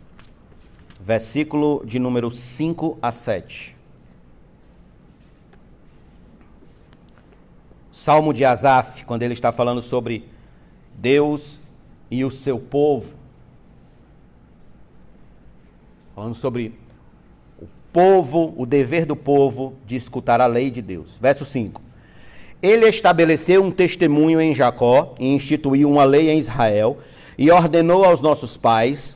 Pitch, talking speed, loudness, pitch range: 130 Hz, 105 wpm, -18 LUFS, 120-150 Hz